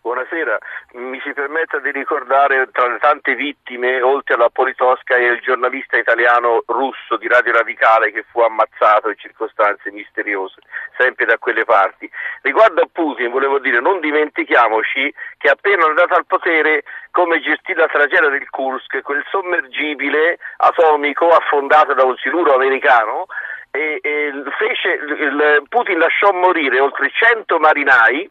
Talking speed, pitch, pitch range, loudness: 145 wpm, 140 Hz, 125-155 Hz, -15 LUFS